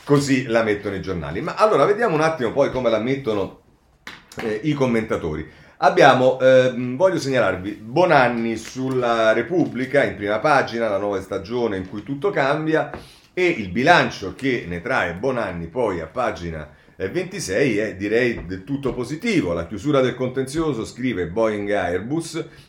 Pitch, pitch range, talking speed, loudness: 120 Hz, 100-140 Hz, 155 wpm, -20 LUFS